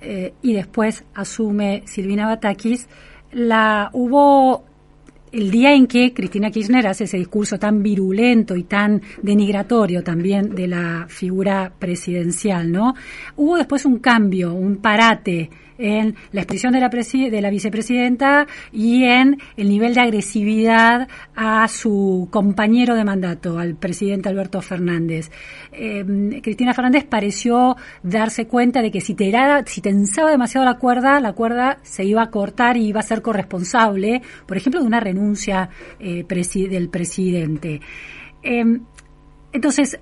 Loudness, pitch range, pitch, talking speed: -17 LUFS, 190-245 Hz, 215 Hz, 140 wpm